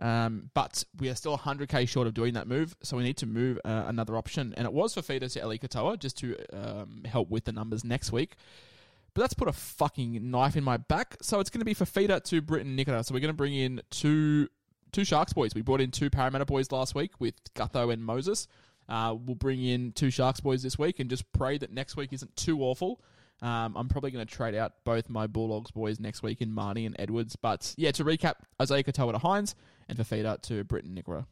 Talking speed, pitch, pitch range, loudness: 245 wpm, 125 Hz, 115-140 Hz, -31 LUFS